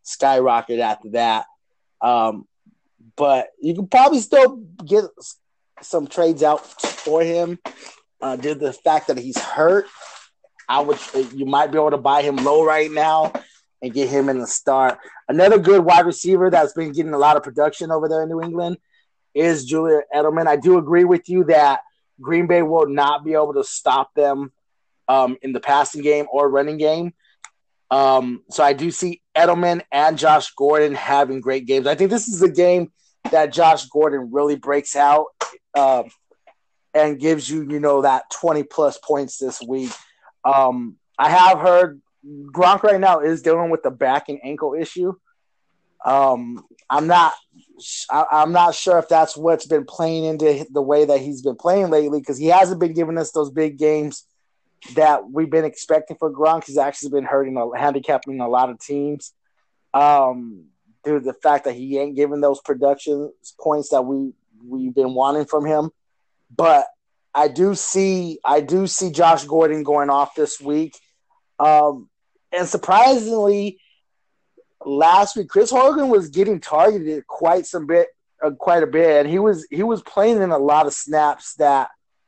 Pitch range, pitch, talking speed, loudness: 140-175 Hz, 155 Hz, 175 wpm, -18 LUFS